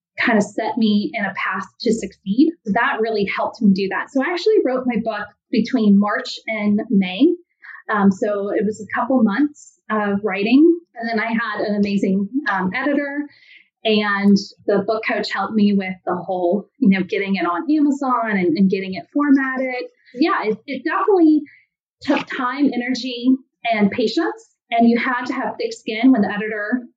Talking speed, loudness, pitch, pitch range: 180 wpm, -19 LUFS, 225 Hz, 205-270 Hz